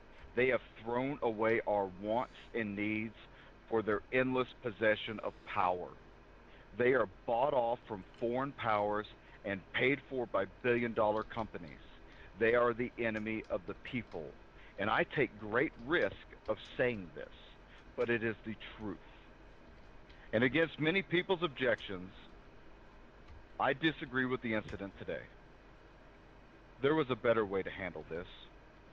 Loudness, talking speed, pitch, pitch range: -35 LUFS, 140 wpm, 115 Hz, 105-130 Hz